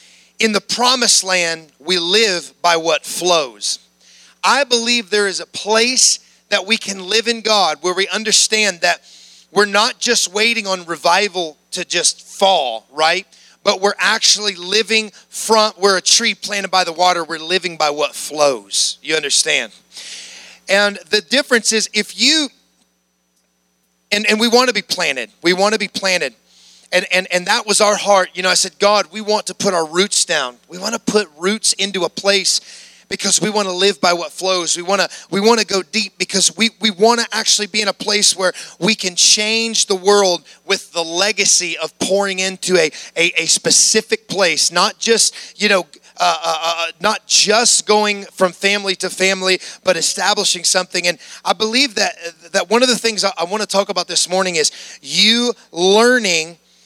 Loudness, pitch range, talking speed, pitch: -15 LUFS, 175-215 Hz, 190 wpm, 195 Hz